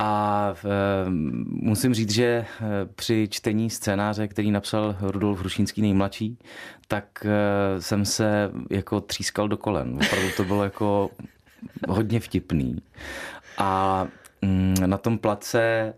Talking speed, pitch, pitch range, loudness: 110 wpm, 105 Hz, 100-110 Hz, -25 LUFS